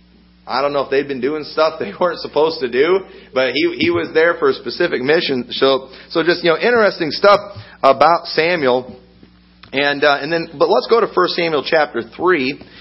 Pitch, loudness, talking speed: 160 Hz, -16 LUFS, 200 wpm